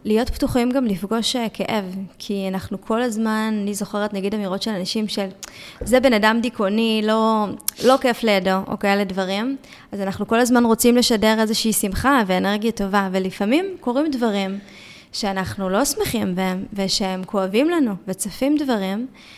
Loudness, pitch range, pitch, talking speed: -20 LUFS, 195-240 Hz, 215 Hz, 150 wpm